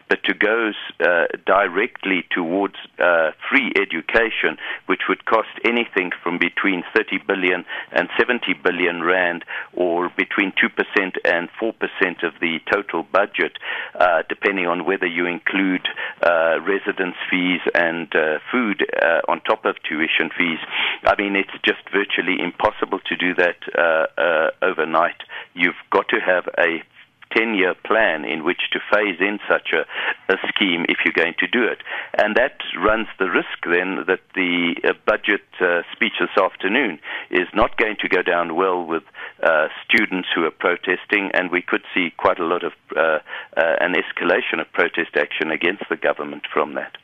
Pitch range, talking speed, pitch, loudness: 85-105 Hz, 165 wpm, 90 Hz, -20 LUFS